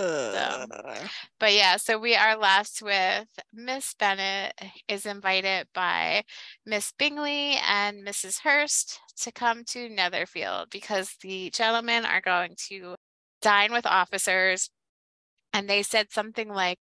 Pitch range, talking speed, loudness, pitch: 190-230 Hz, 130 wpm, -25 LUFS, 205 Hz